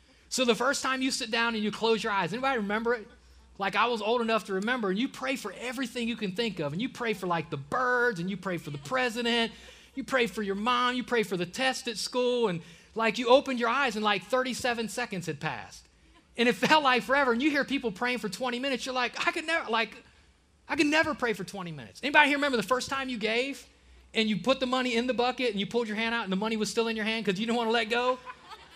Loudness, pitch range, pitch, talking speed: -28 LUFS, 215-255 Hz, 235 Hz, 275 wpm